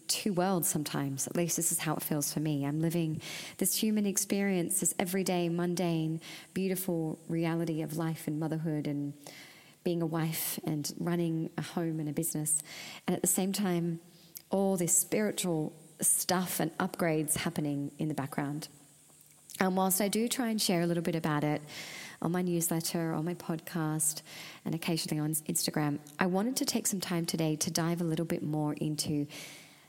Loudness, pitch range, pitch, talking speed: -32 LUFS, 155-180 Hz, 165 Hz, 175 wpm